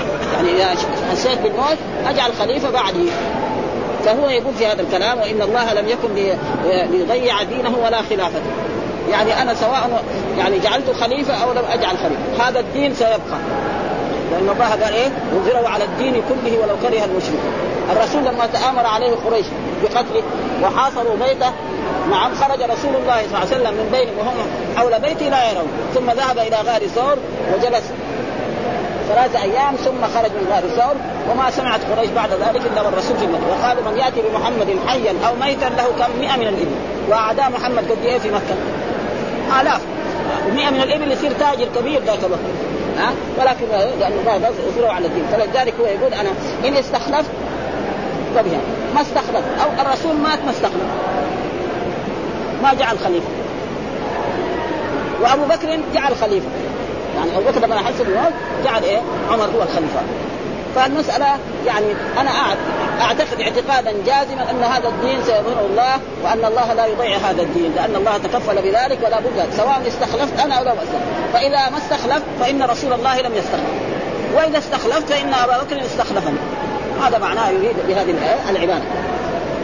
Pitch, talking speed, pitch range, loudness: 250 Hz, 150 wpm, 230-280 Hz, -18 LUFS